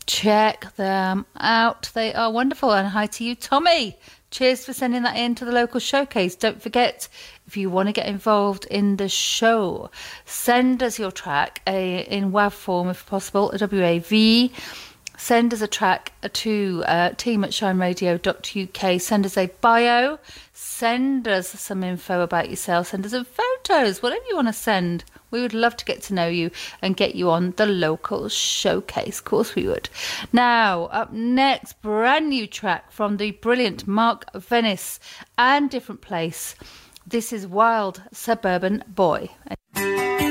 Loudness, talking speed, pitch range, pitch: -21 LUFS, 165 wpm, 190-240 Hz, 215 Hz